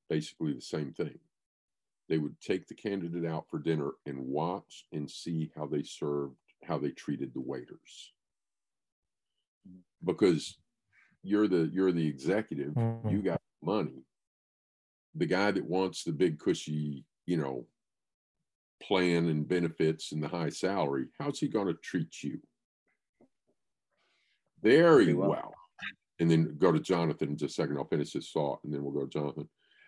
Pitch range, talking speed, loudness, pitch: 75-90 Hz, 150 wpm, -32 LUFS, 80 Hz